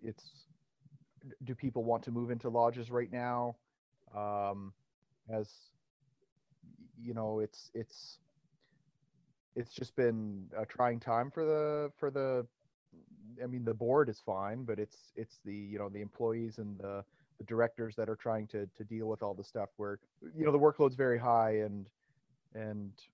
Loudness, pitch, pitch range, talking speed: -36 LUFS, 120 Hz, 110-140 Hz, 165 wpm